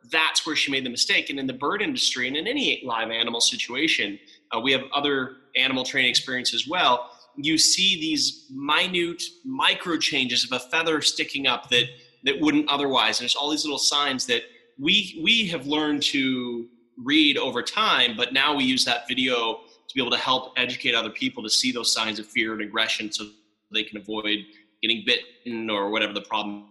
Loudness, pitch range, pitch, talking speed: -22 LUFS, 115-150 Hz, 130 Hz, 200 wpm